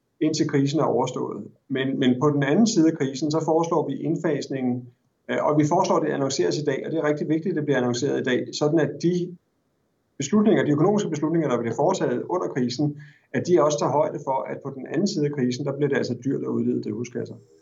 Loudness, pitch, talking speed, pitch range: -24 LUFS, 150 Hz, 235 wpm, 130-160 Hz